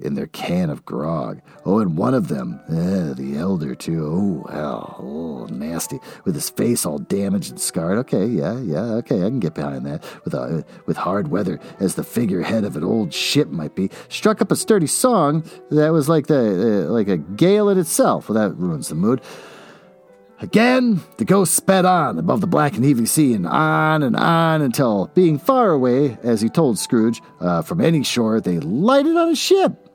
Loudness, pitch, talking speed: -19 LUFS, 155 Hz, 200 wpm